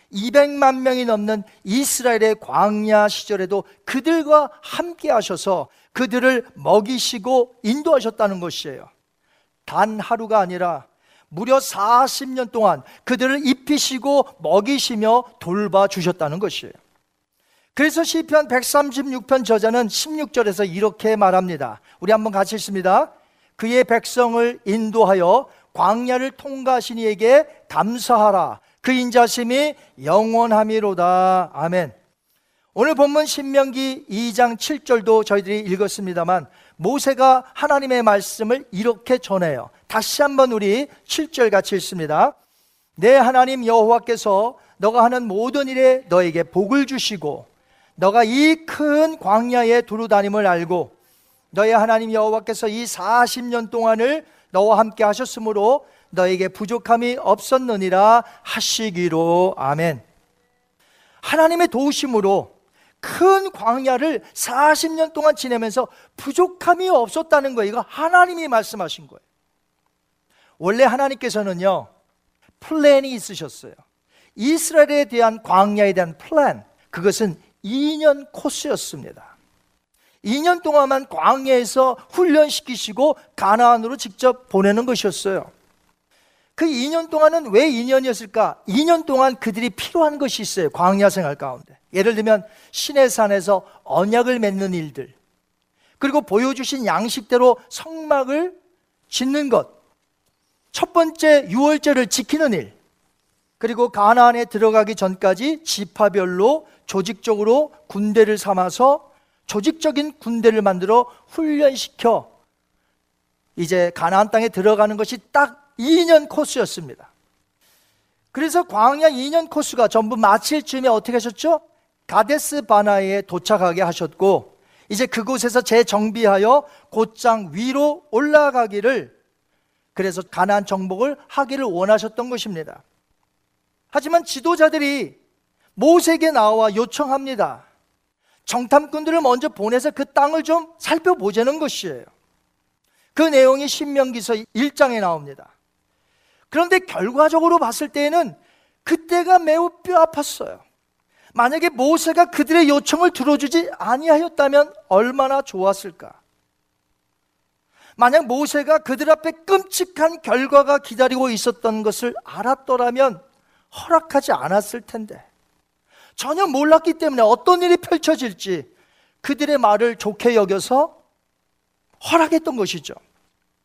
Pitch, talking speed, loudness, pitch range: 240 Hz, 270 characters per minute, -18 LUFS, 205-290 Hz